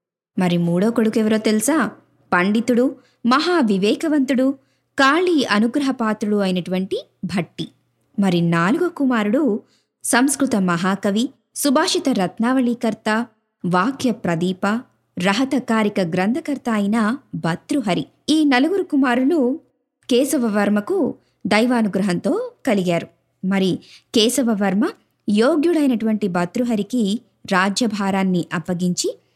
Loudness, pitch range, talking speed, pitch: -19 LUFS, 195-270 Hz, 80 wpm, 225 Hz